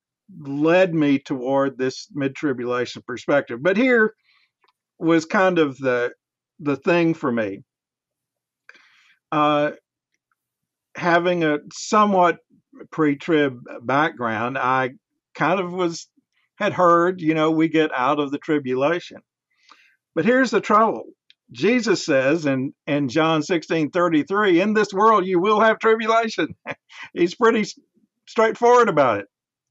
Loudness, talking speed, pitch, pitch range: -20 LUFS, 120 wpm, 165 Hz, 145-210 Hz